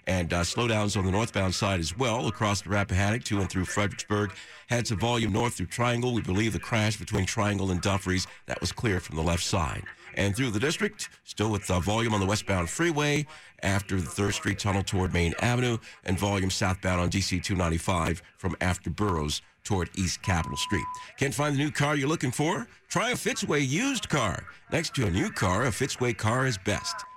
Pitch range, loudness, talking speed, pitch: 95-120 Hz, -28 LUFS, 205 wpm, 105 Hz